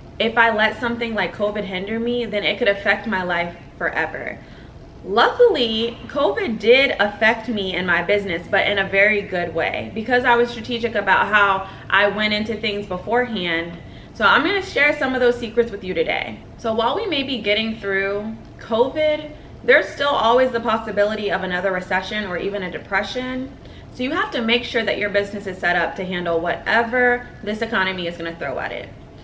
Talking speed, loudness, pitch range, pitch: 195 wpm, -20 LUFS, 190-235 Hz, 210 Hz